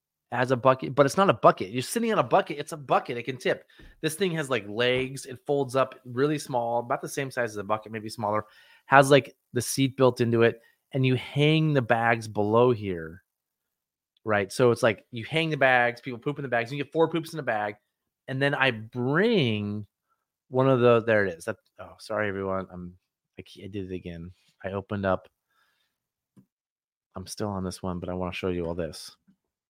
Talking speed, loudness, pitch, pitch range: 220 wpm, -26 LUFS, 120 Hz, 105-135 Hz